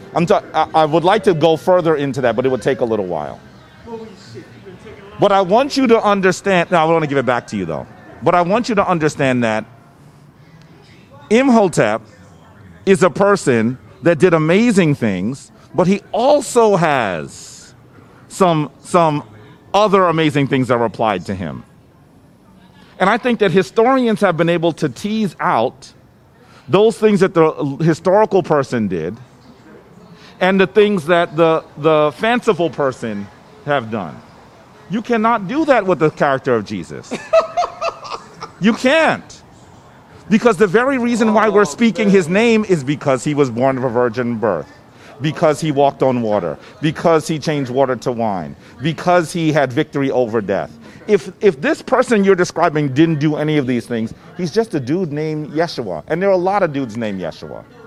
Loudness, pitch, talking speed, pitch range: -16 LUFS, 165 Hz, 170 wpm, 140-200 Hz